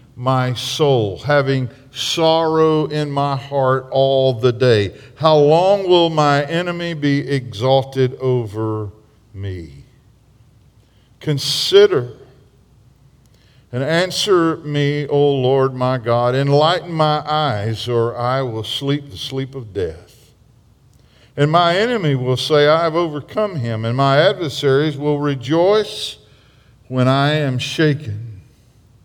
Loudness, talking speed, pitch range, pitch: -17 LUFS, 115 wpm, 120-150 Hz, 135 Hz